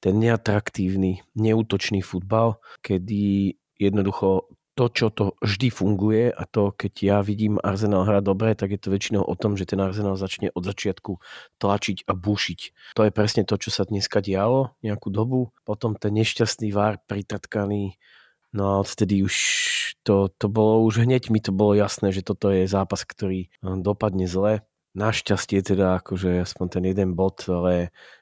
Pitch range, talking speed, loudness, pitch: 95-110 Hz, 165 wpm, -23 LUFS, 100 Hz